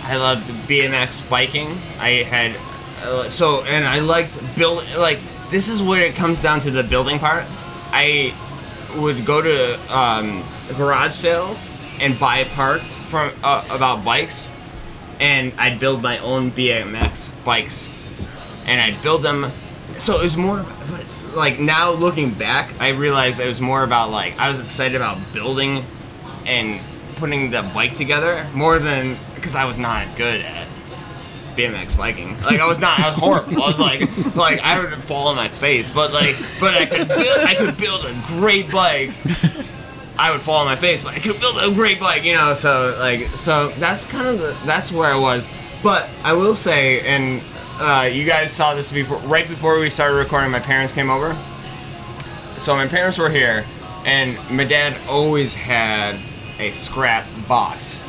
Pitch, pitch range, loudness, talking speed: 140 Hz, 125-155 Hz, -17 LUFS, 175 wpm